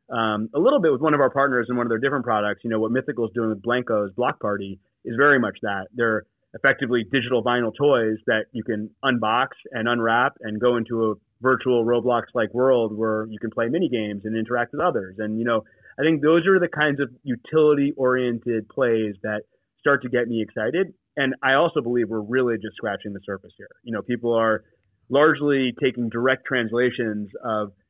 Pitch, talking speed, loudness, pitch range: 120 Hz, 210 wpm, -22 LUFS, 110-130 Hz